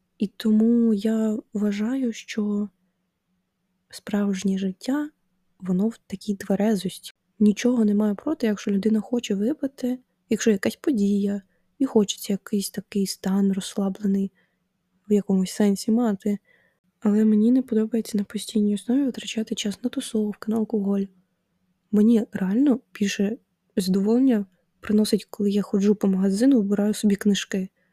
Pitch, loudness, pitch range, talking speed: 205 Hz, -24 LUFS, 195-220 Hz, 125 wpm